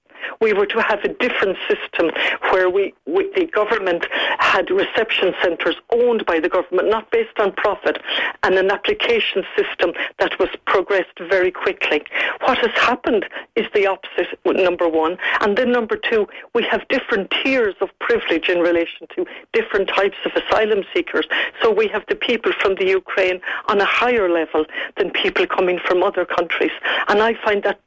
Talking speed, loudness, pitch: 170 wpm, -18 LUFS, 215 Hz